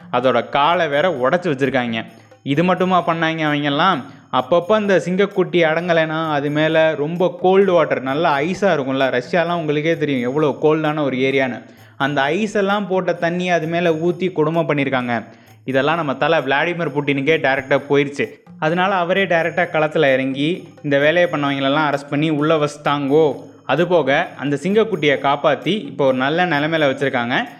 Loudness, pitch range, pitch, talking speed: -18 LUFS, 135-170 Hz, 155 Hz, 145 wpm